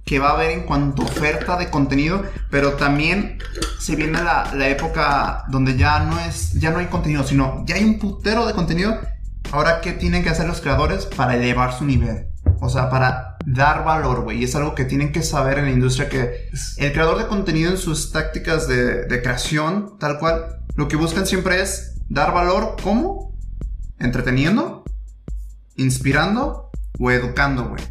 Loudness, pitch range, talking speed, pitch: -20 LUFS, 125-165 Hz, 185 wpm, 145 Hz